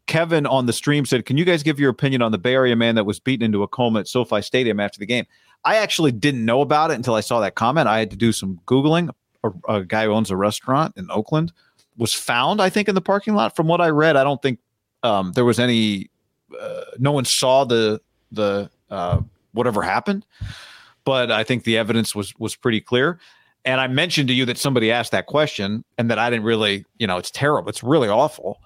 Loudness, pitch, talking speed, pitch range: -20 LUFS, 125 Hz, 235 wpm, 110-145 Hz